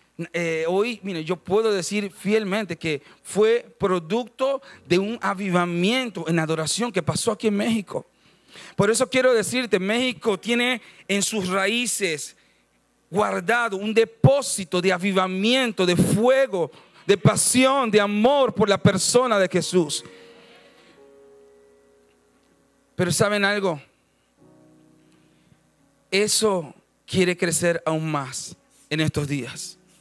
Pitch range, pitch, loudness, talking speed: 160-220 Hz, 190 Hz, -22 LUFS, 110 wpm